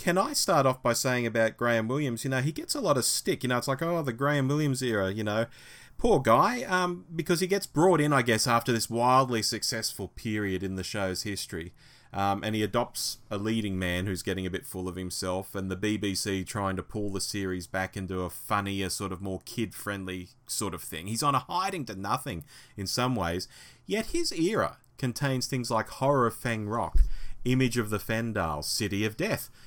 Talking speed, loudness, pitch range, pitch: 215 wpm, -29 LUFS, 95-130 Hz, 110 Hz